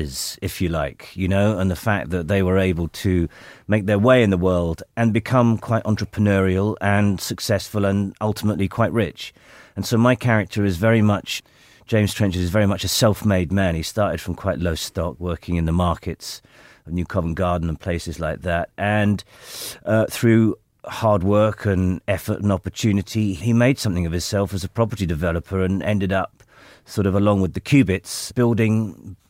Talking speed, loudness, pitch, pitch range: 185 wpm, -21 LUFS, 100 Hz, 90-105 Hz